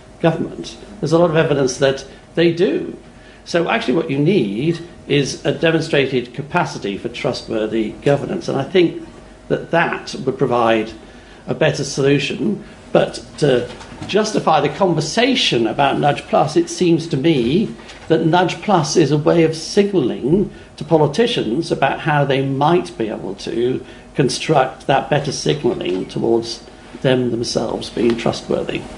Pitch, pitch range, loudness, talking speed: 145 Hz, 125-170 Hz, -18 LUFS, 145 wpm